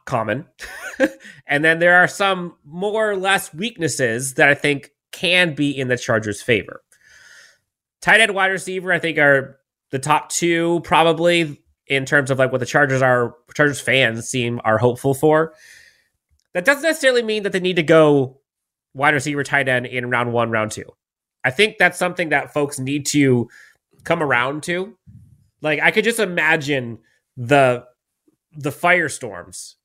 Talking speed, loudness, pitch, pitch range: 165 wpm, -18 LUFS, 145 Hz, 130-175 Hz